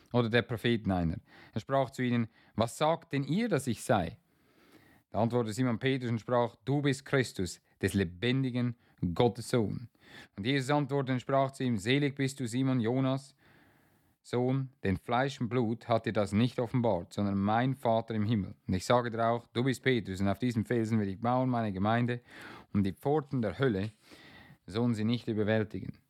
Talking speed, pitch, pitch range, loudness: 185 wpm, 120 Hz, 110-130 Hz, -31 LUFS